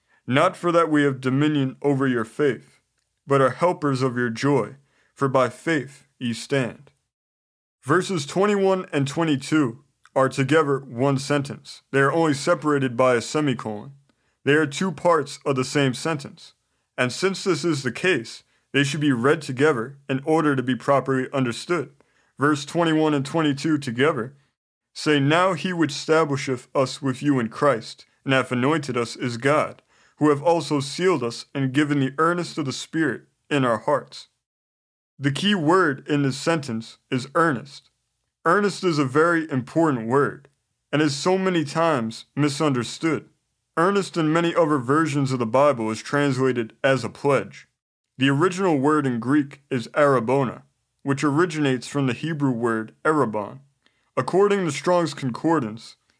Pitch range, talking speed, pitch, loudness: 130-160 Hz, 155 wpm, 140 Hz, -22 LUFS